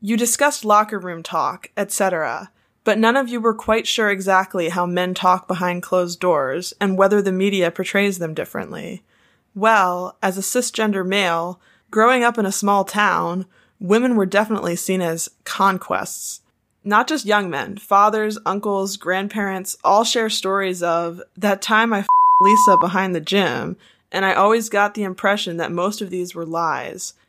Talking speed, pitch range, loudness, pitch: 165 wpm, 185-215 Hz, -19 LUFS, 200 Hz